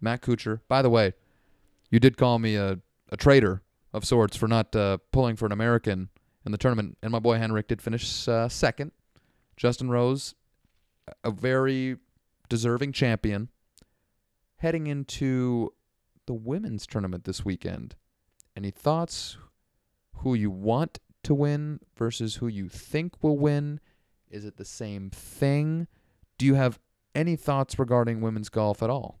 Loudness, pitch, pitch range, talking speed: -27 LUFS, 115 Hz, 100-130 Hz, 150 wpm